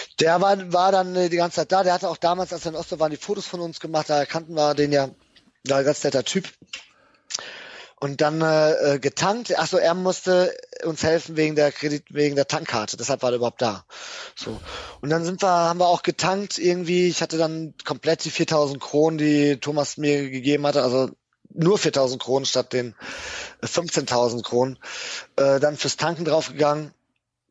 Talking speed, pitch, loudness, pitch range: 190 wpm, 155 Hz, -22 LUFS, 140-175 Hz